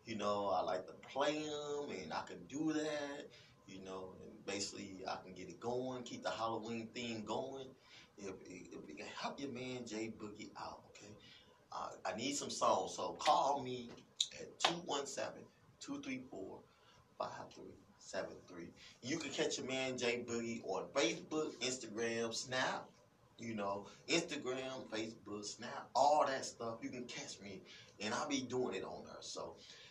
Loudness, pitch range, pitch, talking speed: -41 LUFS, 110-130 Hz, 120 Hz, 150 wpm